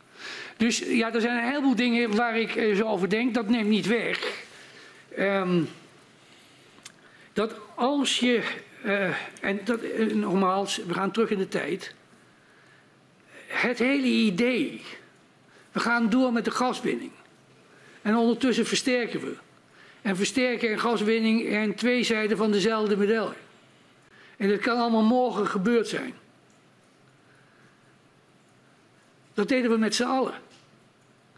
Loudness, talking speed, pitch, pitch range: -25 LUFS, 130 wpm, 225 Hz, 210-240 Hz